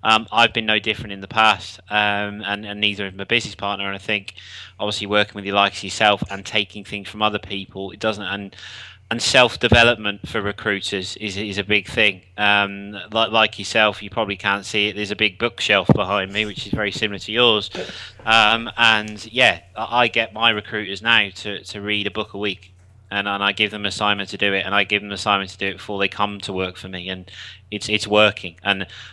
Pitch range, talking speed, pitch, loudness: 100-110 Hz, 225 wpm, 105 Hz, -19 LUFS